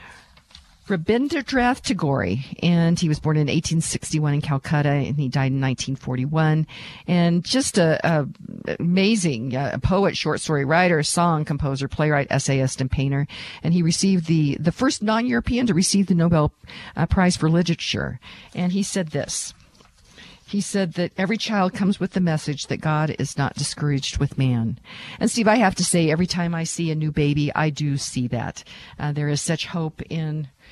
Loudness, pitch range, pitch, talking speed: -22 LUFS, 145-185 Hz, 160 Hz, 175 wpm